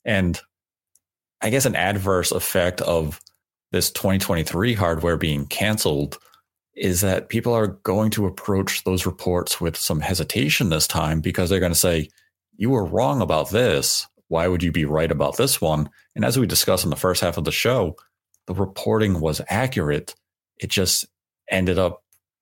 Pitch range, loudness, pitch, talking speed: 80-95 Hz, -21 LUFS, 90 Hz, 170 wpm